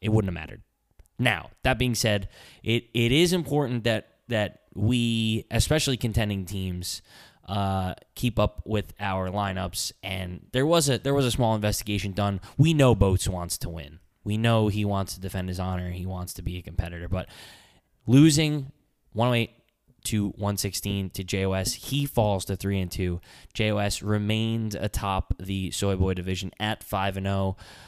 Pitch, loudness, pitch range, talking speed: 100 Hz, -26 LUFS, 95-115 Hz, 170 wpm